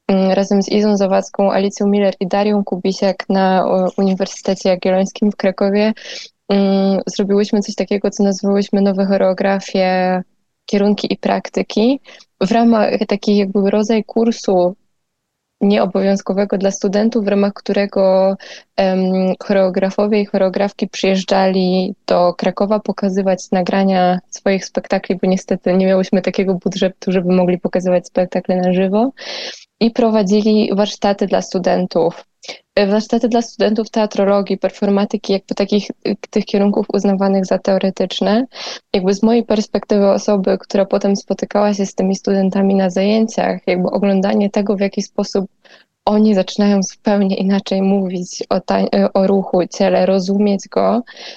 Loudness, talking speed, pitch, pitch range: -16 LUFS, 125 wpm, 200 Hz, 190-210 Hz